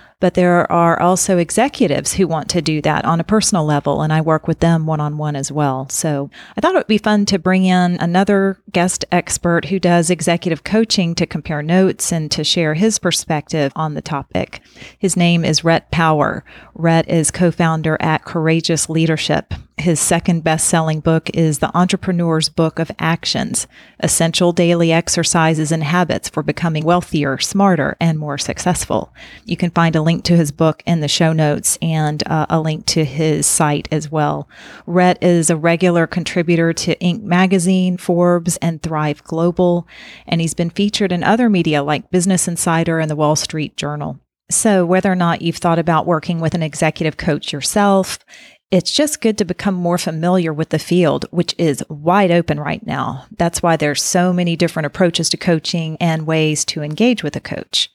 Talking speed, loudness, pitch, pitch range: 185 wpm, -16 LUFS, 170 Hz, 155-180 Hz